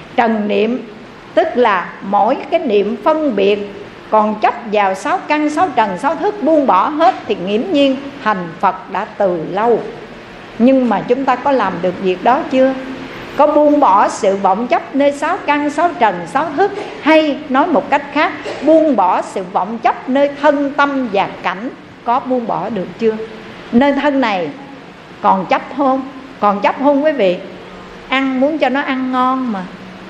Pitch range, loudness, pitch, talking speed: 215-290 Hz, -15 LUFS, 265 Hz, 180 wpm